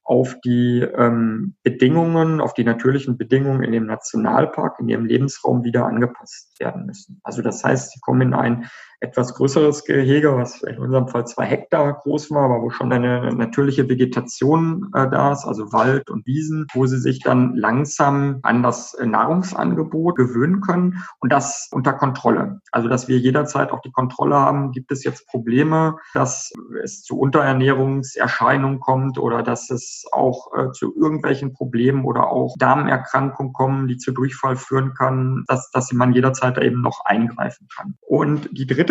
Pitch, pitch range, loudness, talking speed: 130 Hz, 125-145 Hz, -19 LUFS, 165 wpm